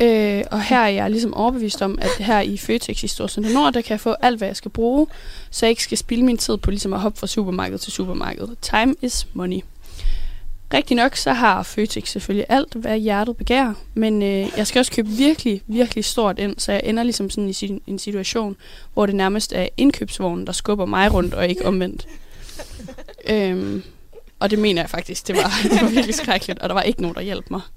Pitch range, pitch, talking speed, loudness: 195-230 Hz, 210 Hz, 225 wpm, -20 LUFS